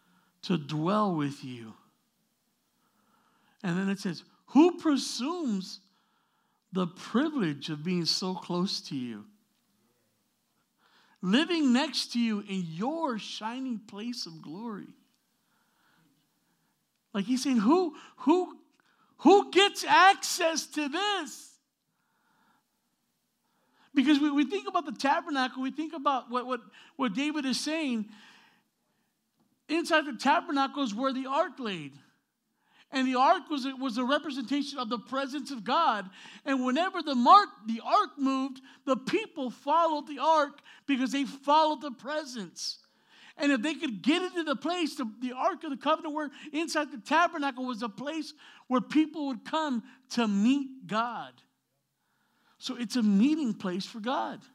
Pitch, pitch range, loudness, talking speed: 265 Hz, 225-300 Hz, -29 LUFS, 140 wpm